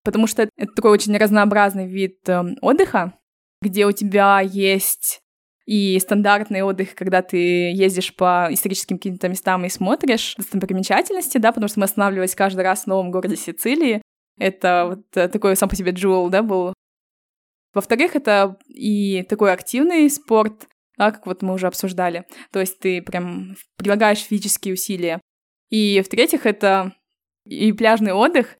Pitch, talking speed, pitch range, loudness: 200 Hz, 150 wpm, 185-215 Hz, -19 LUFS